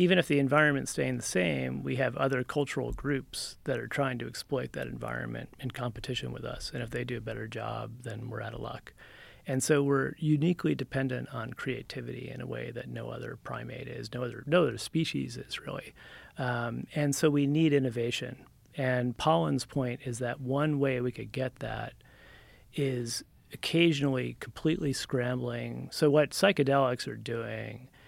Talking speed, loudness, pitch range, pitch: 175 wpm, -31 LUFS, 120-145 Hz, 130 Hz